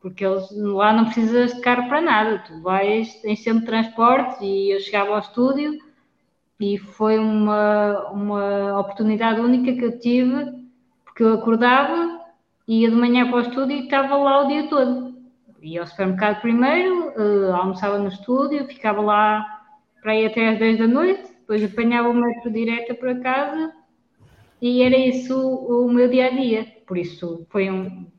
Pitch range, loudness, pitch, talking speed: 210-255 Hz, -20 LUFS, 230 Hz, 165 wpm